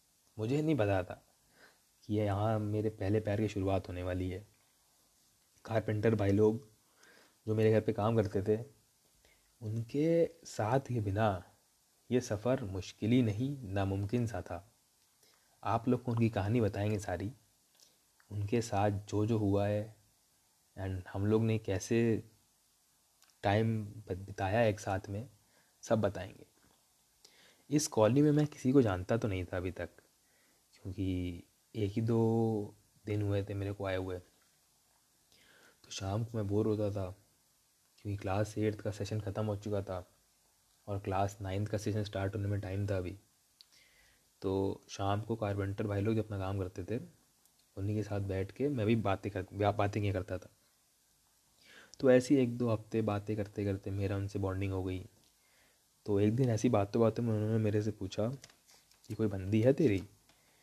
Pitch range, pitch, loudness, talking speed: 100-110 Hz, 105 Hz, -34 LUFS, 165 wpm